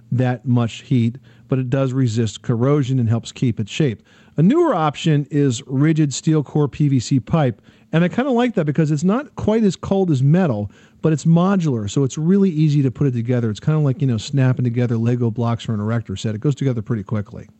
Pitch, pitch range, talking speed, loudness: 135 Hz, 115-155 Hz, 225 wpm, -19 LUFS